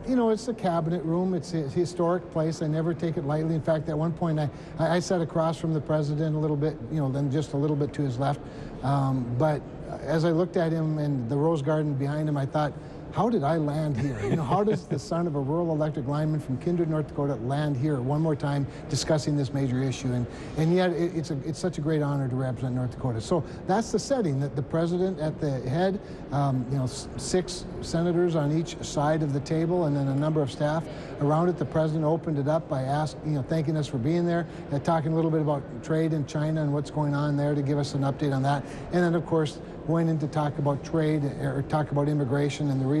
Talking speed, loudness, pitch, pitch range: 255 wpm, -27 LUFS, 155 Hz, 145-165 Hz